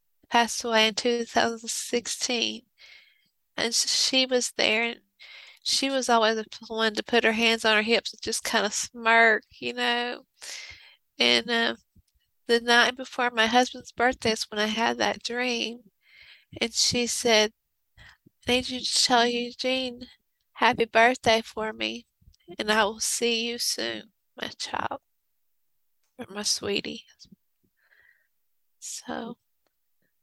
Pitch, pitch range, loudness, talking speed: 230 Hz, 215-240 Hz, -24 LUFS, 135 wpm